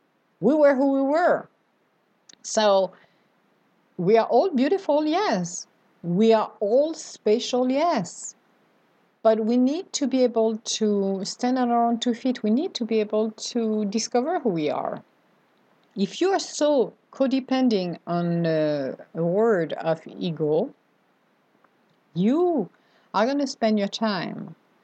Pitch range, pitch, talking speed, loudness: 200-265 Hz, 225 Hz, 135 wpm, -23 LUFS